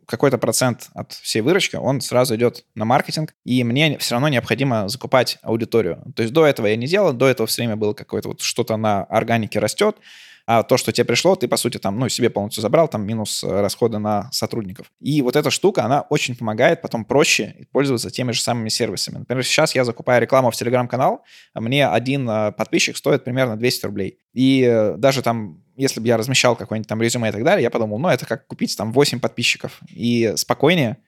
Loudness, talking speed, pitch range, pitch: -19 LUFS, 205 wpm, 110-130 Hz, 120 Hz